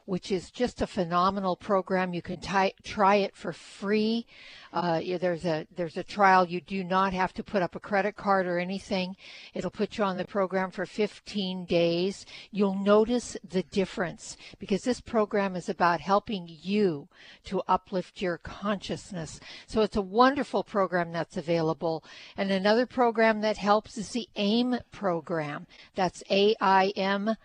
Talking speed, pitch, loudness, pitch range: 160 wpm, 195 Hz, -28 LUFS, 180-210 Hz